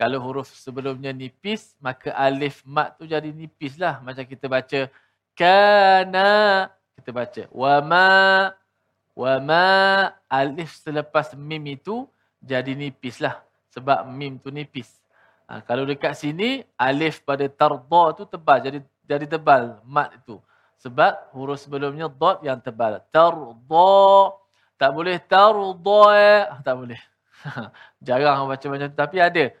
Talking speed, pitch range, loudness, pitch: 130 wpm, 135-185 Hz, -19 LUFS, 150 Hz